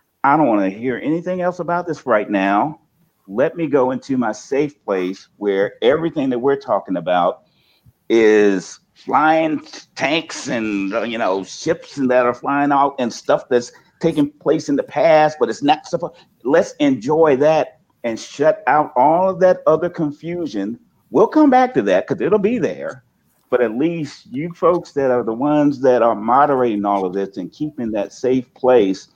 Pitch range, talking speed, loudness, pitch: 125-170 Hz, 180 wpm, -18 LUFS, 150 Hz